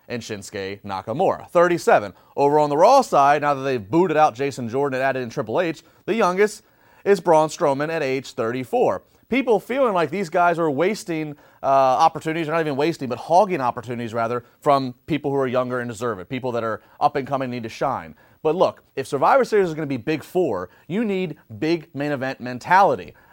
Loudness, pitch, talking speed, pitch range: -21 LUFS, 145 Hz, 205 wpm, 125-165 Hz